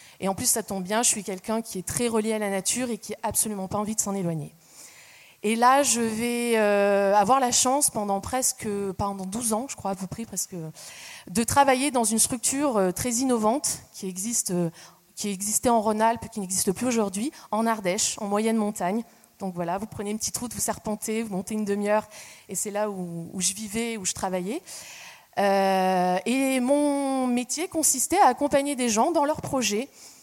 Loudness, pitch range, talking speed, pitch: -25 LUFS, 195-245 Hz, 200 wpm, 220 Hz